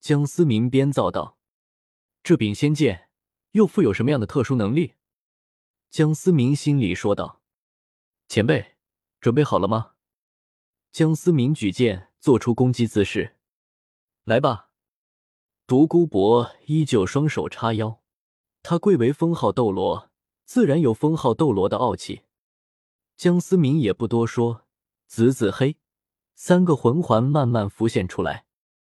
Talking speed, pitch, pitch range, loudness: 195 characters per minute, 120 Hz, 100-155 Hz, -21 LUFS